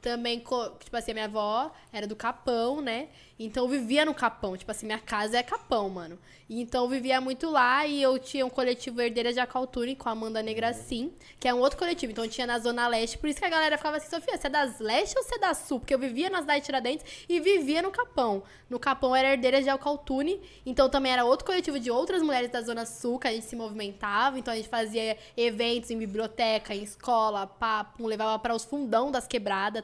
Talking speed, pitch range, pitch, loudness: 235 wpm, 225-275 Hz, 245 Hz, -29 LUFS